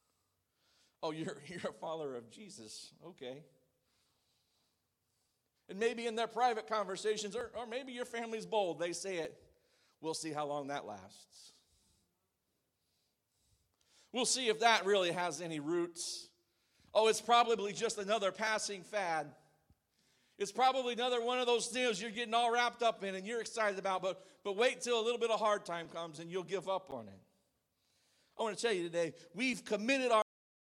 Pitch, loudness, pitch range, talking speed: 205 Hz, -36 LUFS, 170-235 Hz, 170 wpm